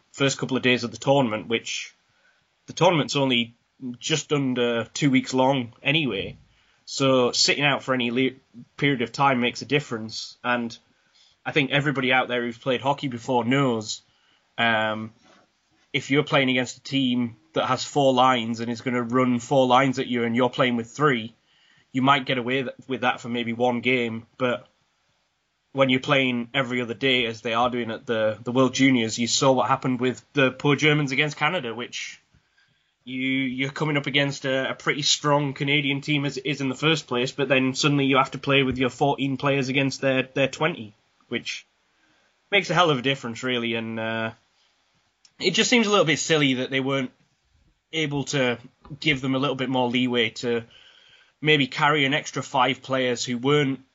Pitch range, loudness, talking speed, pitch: 120-140 Hz, -23 LUFS, 190 wpm, 130 Hz